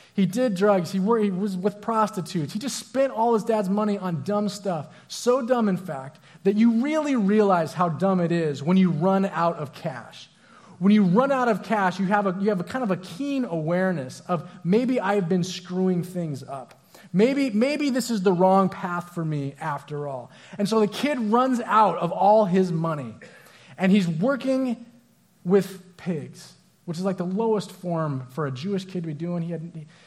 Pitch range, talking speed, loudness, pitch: 170-215 Hz, 200 wpm, -24 LUFS, 190 Hz